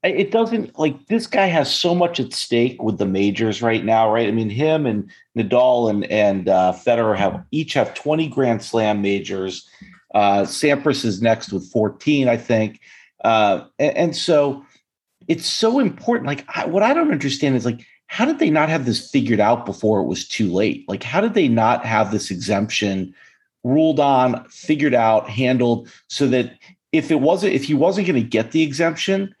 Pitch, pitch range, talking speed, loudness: 125 Hz, 110-160 Hz, 190 wpm, -19 LUFS